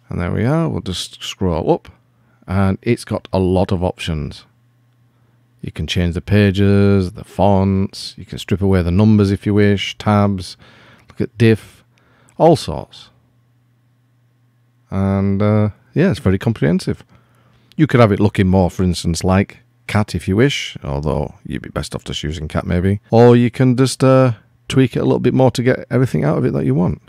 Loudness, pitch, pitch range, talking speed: -16 LUFS, 105 Hz, 95-120 Hz, 190 wpm